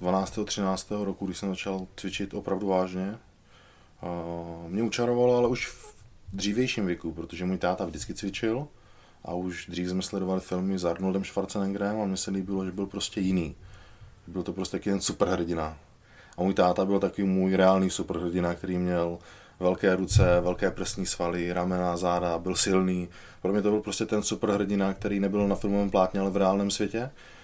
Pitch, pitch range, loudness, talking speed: 95 Hz, 90-100 Hz, -28 LUFS, 175 wpm